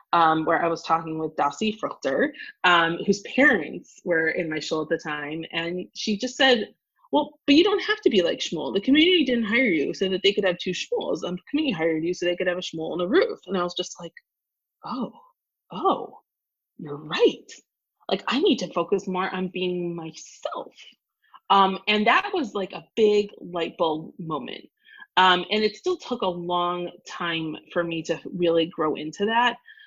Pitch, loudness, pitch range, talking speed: 185 Hz, -24 LUFS, 170-270 Hz, 200 wpm